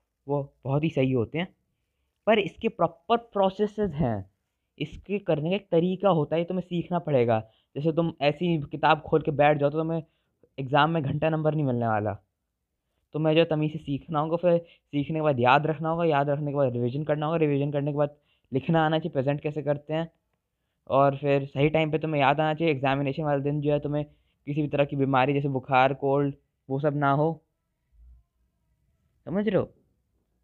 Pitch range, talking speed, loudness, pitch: 135-160 Hz, 200 wpm, -26 LUFS, 150 Hz